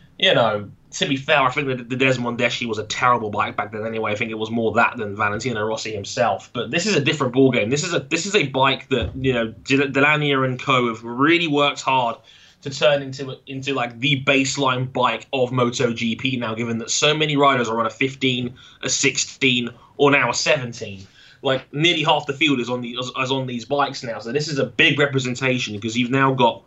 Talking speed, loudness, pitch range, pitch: 225 wpm, -20 LUFS, 120-140 Hz, 130 Hz